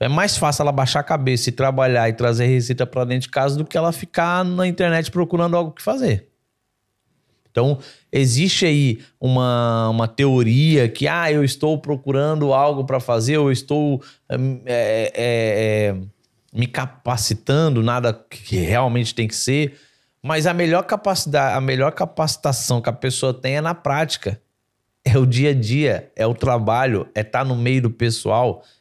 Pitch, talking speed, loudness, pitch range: 130 Hz, 175 wpm, -19 LUFS, 120-150 Hz